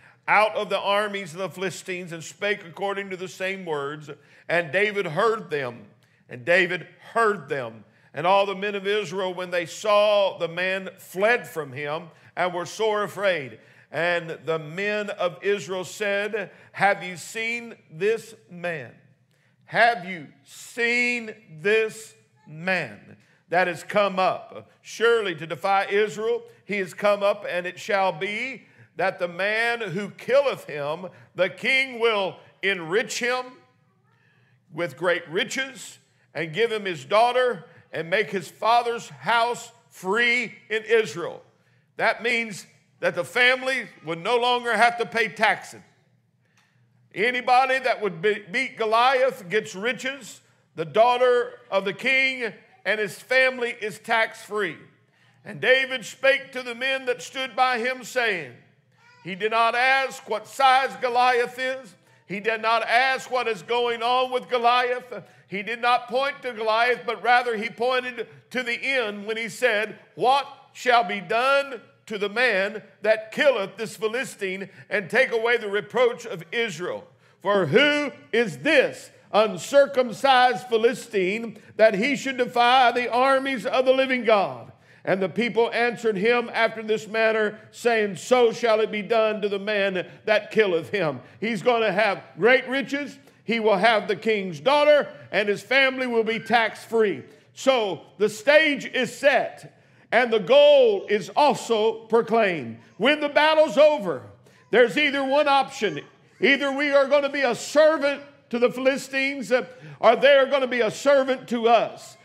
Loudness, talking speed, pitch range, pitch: -23 LUFS, 150 wpm, 190-250 Hz, 220 Hz